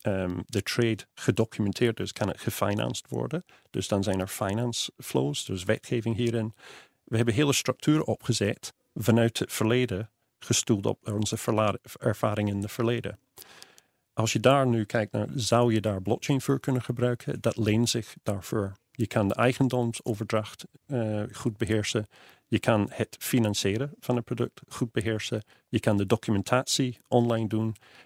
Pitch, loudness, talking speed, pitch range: 115 Hz, -28 LUFS, 155 wpm, 105-125 Hz